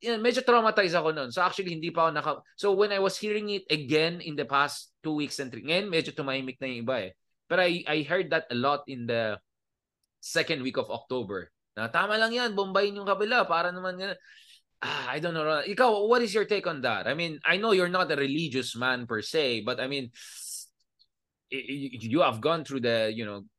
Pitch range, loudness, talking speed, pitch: 130-195 Hz, -28 LUFS, 175 wpm, 155 Hz